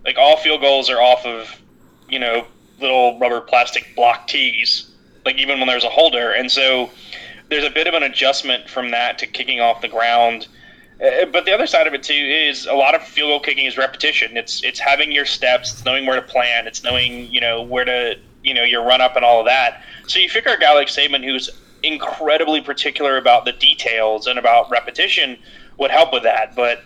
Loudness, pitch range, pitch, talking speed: -15 LUFS, 120-140 Hz, 125 Hz, 215 wpm